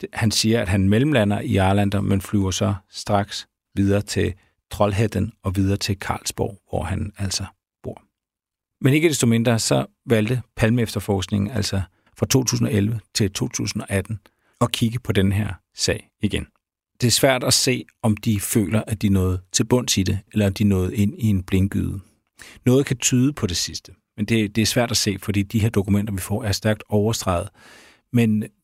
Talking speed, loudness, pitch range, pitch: 180 wpm, -21 LUFS, 100-115 Hz, 105 Hz